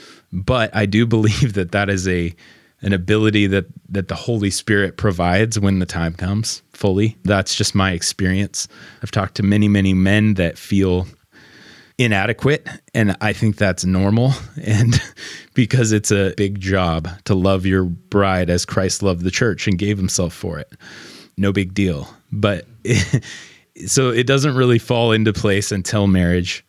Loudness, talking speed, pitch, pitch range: -18 LUFS, 165 wpm, 100 Hz, 95-110 Hz